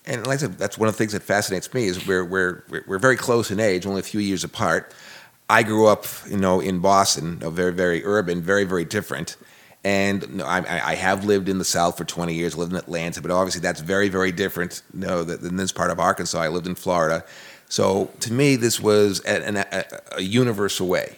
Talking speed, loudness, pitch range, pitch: 235 wpm, -22 LUFS, 90-105 Hz, 95 Hz